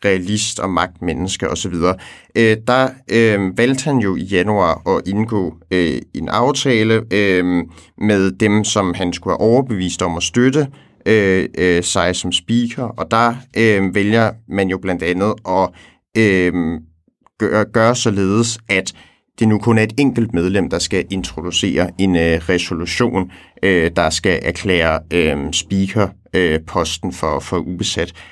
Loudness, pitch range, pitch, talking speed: -16 LUFS, 90-110 Hz, 95 Hz, 150 wpm